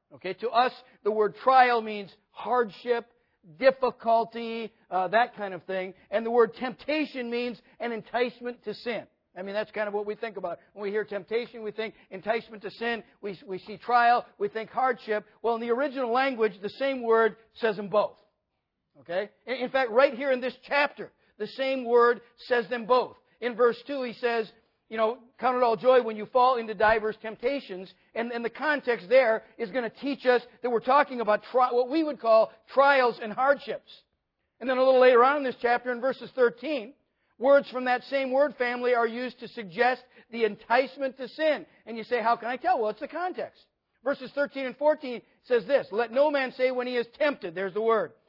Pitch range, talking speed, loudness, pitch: 220-255 Hz, 205 wpm, -27 LUFS, 240 Hz